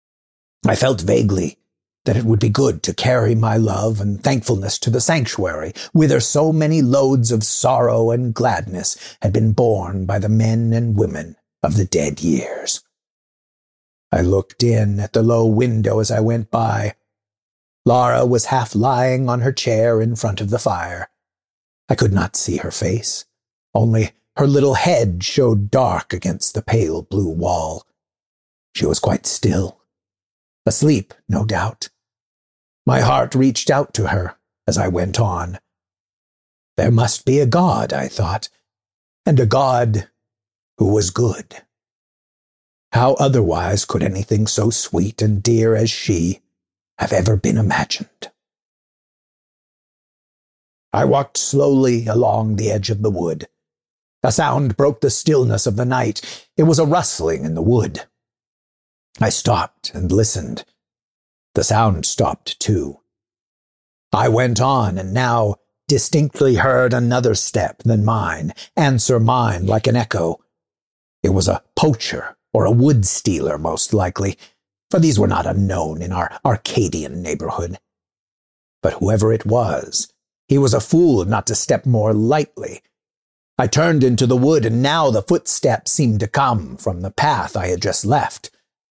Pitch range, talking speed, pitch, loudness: 95-125 Hz, 150 wpm, 110 Hz, -17 LUFS